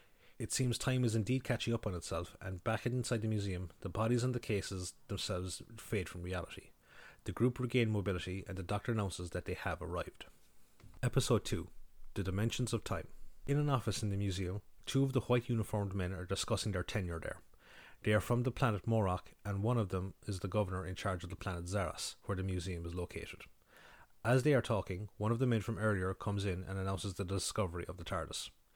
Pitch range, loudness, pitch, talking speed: 95-115 Hz, -37 LUFS, 100 Hz, 210 wpm